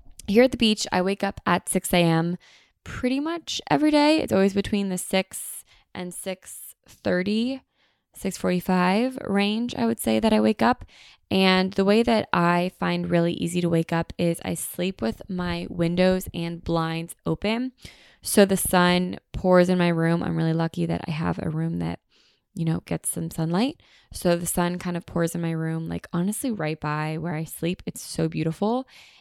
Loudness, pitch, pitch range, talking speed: -24 LUFS, 180 Hz, 165-200 Hz, 185 wpm